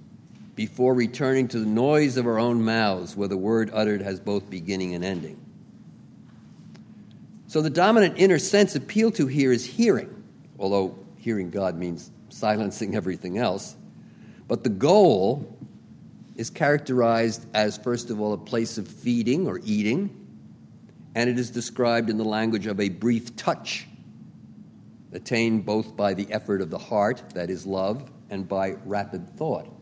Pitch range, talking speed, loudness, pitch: 100-125 Hz, 155 wpm, -24 LUFS, 115 Hz